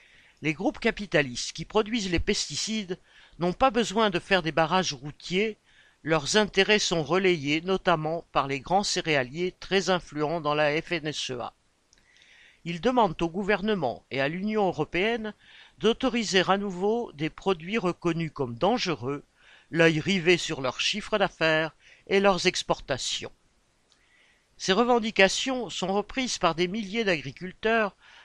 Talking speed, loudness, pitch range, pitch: 130 wpm, -26 LUFS, 160-210 Hz, 185 Hz